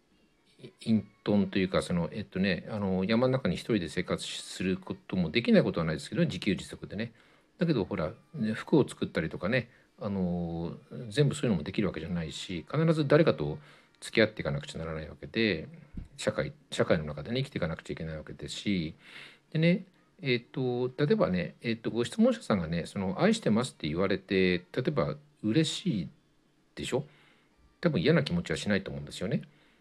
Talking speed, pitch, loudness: 355 characters per minute, 120 Hz, -30 LUFS